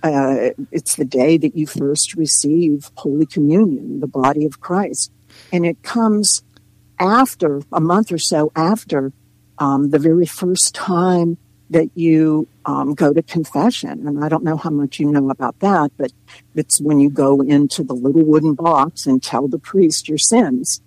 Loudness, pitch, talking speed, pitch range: -16 LUFS, 155 Hz, 175 wpm, 140-175 Hz